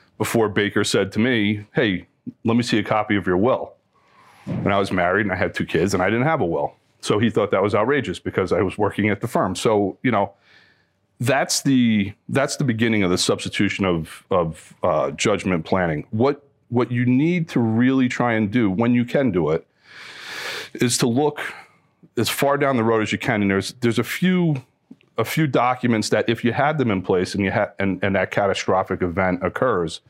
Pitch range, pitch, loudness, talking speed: 100-125 Hz, 110 Hz, -21 LUFS, 215 wpm